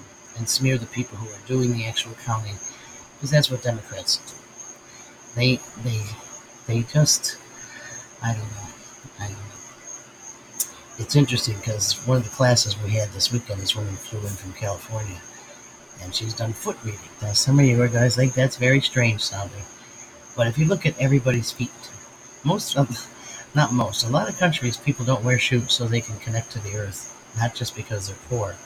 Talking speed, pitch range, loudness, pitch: 185 wpm, 110-125 Hz, -23 LUFS, 115 Hz